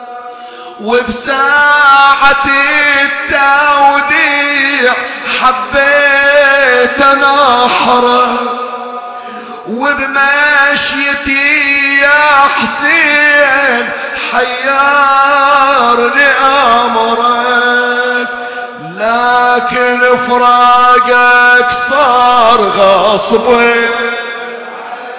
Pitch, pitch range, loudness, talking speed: 245 Hz, 245-280 Hz, -7 LUFS, 30 wpm